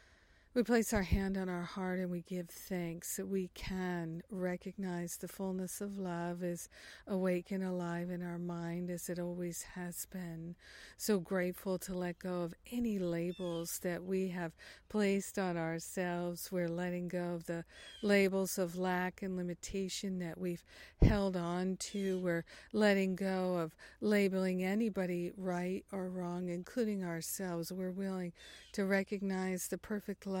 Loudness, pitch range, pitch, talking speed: -38 LUFS, 175-195 Hz, 185 Hz, 155 wpm